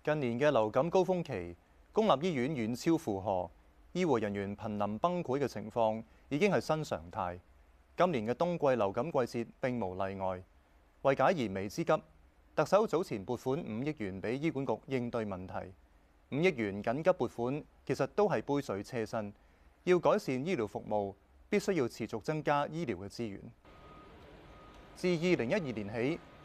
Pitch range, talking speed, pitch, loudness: 95-140 Hz, 250 characters per minute, 115 Hz, -34 LUFS